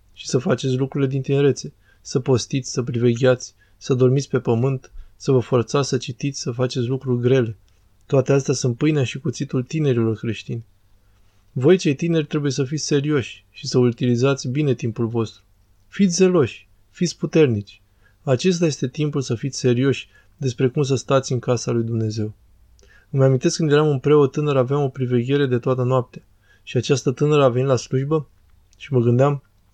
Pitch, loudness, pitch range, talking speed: 130 Hz, -20 LUFS, 110-140 Hz, 170 wpm